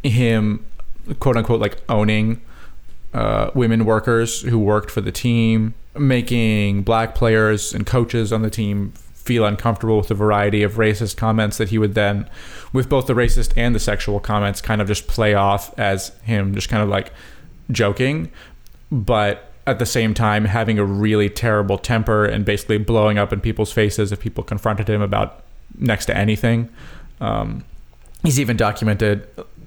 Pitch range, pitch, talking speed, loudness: 105-115 Hz, 110 Hz, 165 wpm, -19 LUFS